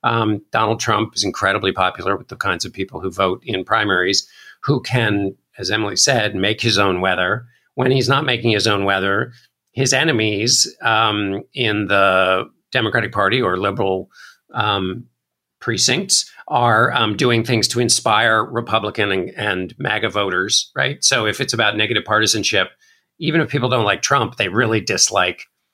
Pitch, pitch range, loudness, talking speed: 110 Hz, 100-120 Hz, -17 LUFS, 160 wpm